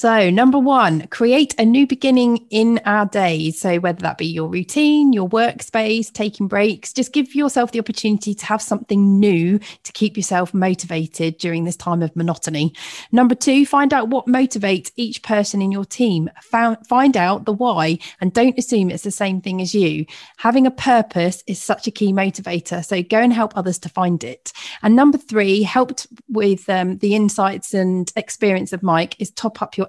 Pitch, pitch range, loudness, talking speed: 205 Hz, 185-235 Hz, -17 LUFS, 190 wpm